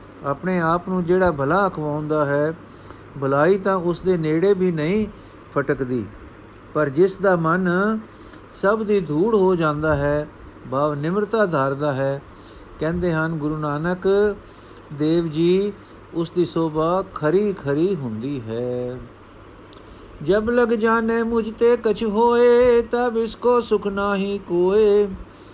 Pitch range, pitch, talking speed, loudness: 140-200 Hz, 170 Hz, 125 wpm, -20 LUFS